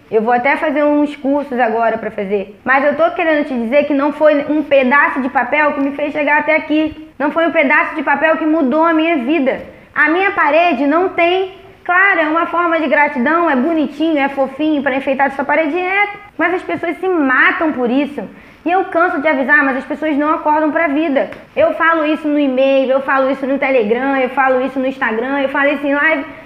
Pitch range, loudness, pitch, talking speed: 275-320 Hz, -14 LUFS, 295 Hz, 225 wpm